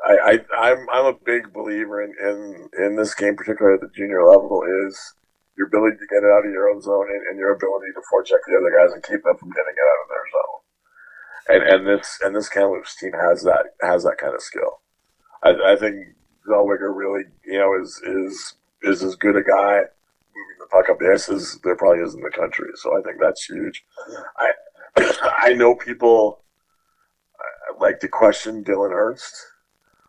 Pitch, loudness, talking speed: 115 Hz, -19 LUFS, 200 wpm